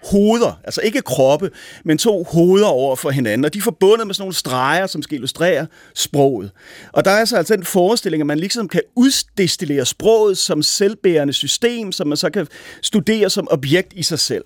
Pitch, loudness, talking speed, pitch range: 180 Hz, -16 LUFS, 200 wpm, 150-205 Hz